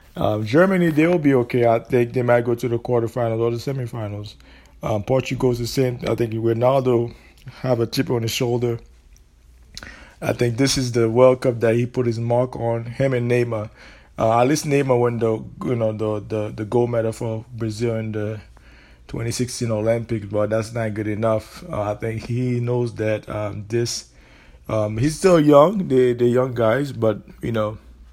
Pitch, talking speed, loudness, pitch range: 115 Hz, 190 wpm, -21 LUFS, 110-125 Hz